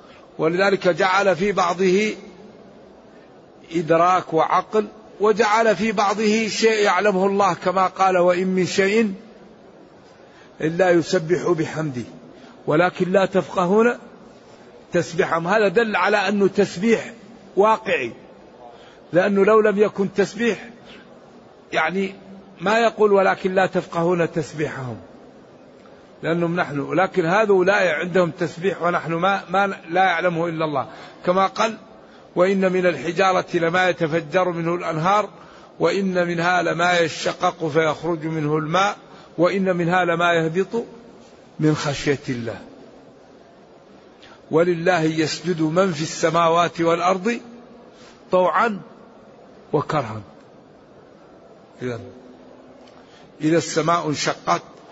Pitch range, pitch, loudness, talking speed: 165-200 Hz, 180 Hz, -20 LUFS, 100 wpm